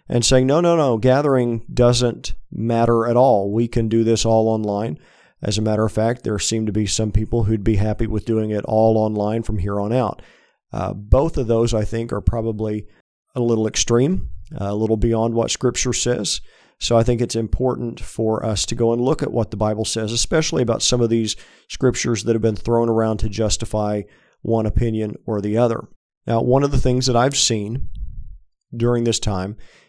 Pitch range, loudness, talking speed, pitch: 105-120 Hz, -19 LUFS, 205 wpm, 115 Hz